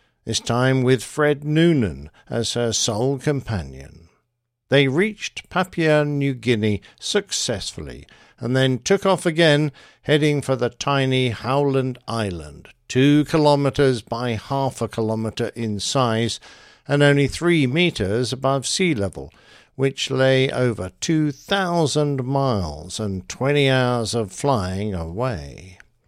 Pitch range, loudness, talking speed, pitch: 110-145 Hz, -21 LUFS, 120 wpm, 130 Hz